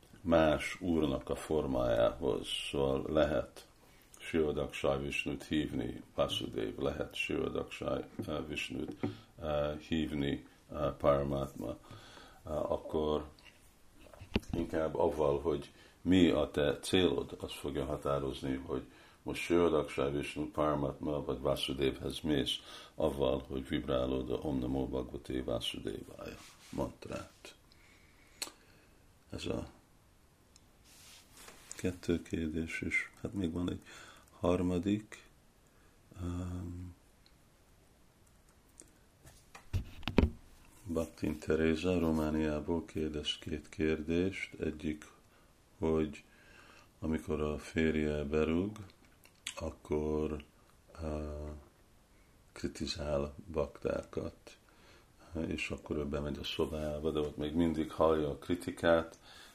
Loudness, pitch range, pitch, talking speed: -36 LUFS, 75-85 Hz, 80 Hz, 80 wpm